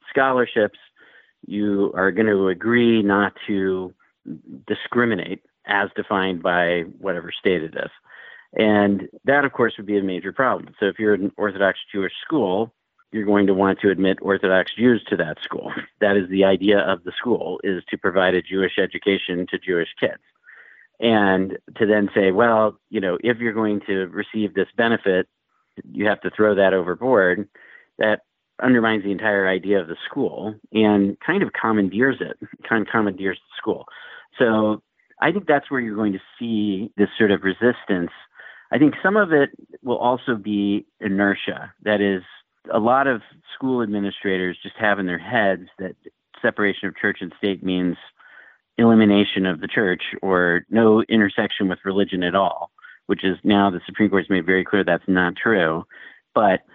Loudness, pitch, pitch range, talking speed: -20 LUFS, 100 Hz, 95-110 Hz, 175 wpm